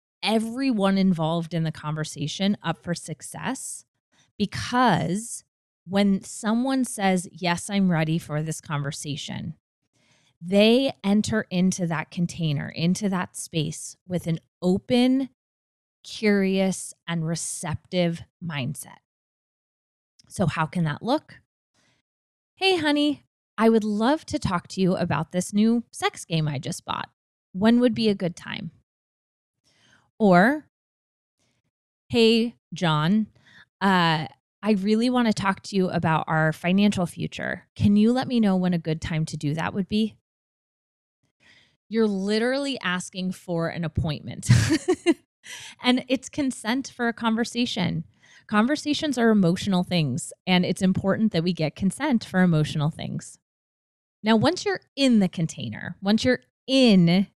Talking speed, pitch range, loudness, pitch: 130 wpm, 165-225 Hz, -24 LUFS, 185 Hz